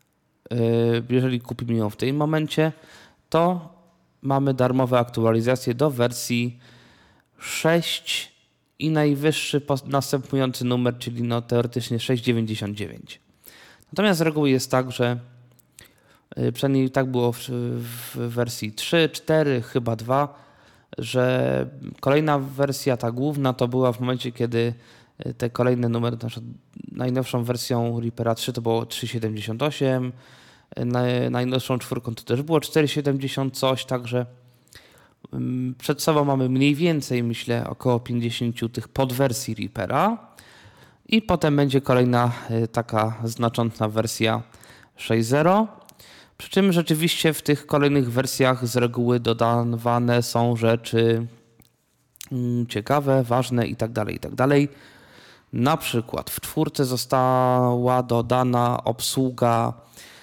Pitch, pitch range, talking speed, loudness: 125 Hz, 120-135 Hz, 110 wpm, -23 LUFS